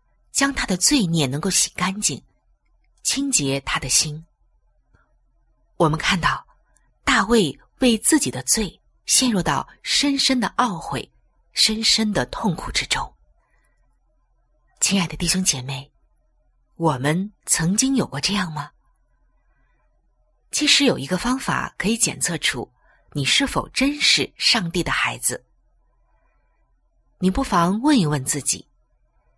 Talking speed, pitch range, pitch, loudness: 180 characters per minute, 155-250 Hz, 190 Hz, -20 LUFS